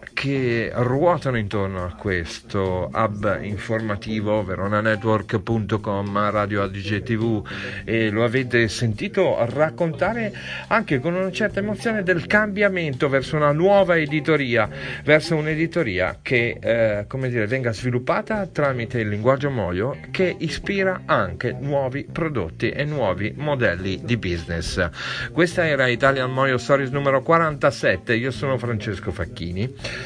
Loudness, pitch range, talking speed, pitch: -22 LUFS, 105-150 Hz, 120 wpm, 125 Hz